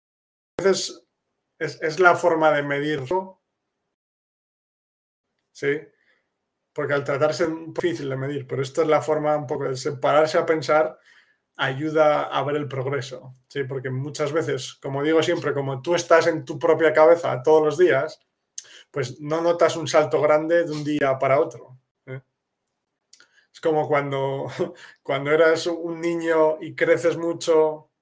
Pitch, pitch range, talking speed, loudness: 155 Hz, 140-165 Hz, 150 wpm, -22 LUFS